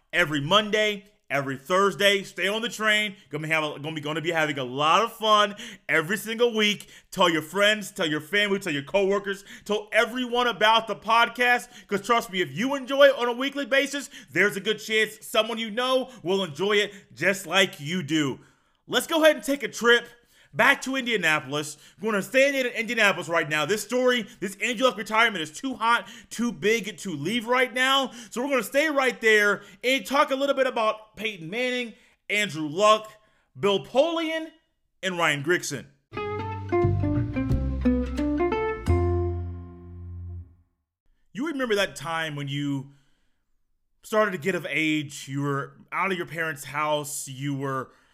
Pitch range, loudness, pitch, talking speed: 155-235 Hz, -24 LUFS, 205 Hz, 170 wpm